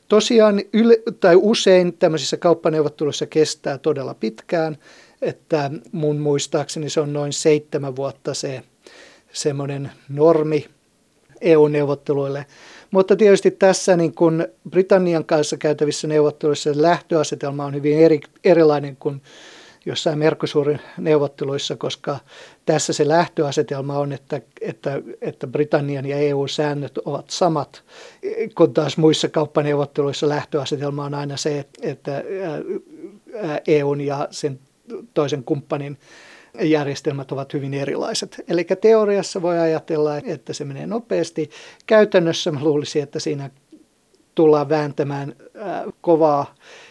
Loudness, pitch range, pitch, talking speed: -20 LUFS, 145-170 Hz, 155 Hz, 110 wpm